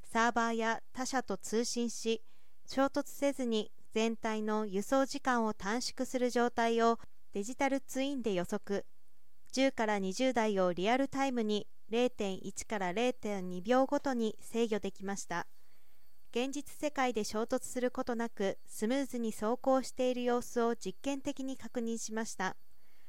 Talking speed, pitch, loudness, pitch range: 265 characters per minute, 230 Hz, -35 LUFS, 215-260 Hz